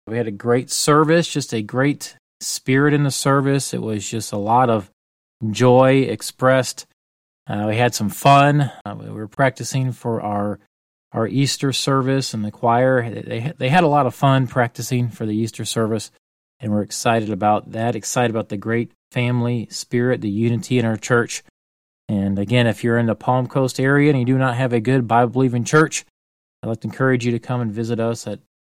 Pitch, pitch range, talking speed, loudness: 120 Hz, 110-130 Hz, 200 wpm, -19 LUFS